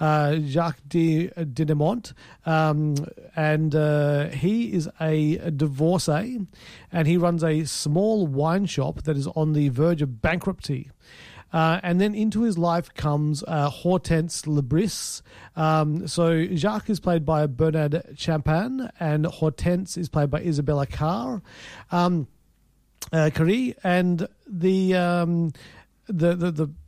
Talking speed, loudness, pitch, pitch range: 135 wpm, -24 LUFS, 160 Hz, 150-175 Hz